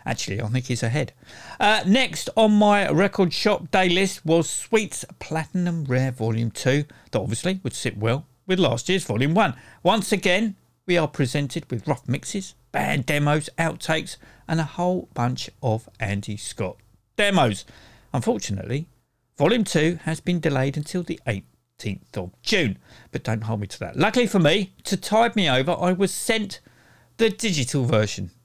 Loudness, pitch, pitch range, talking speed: -23 LUFS, 155 Hz, 120-190 Hz, 165 wpm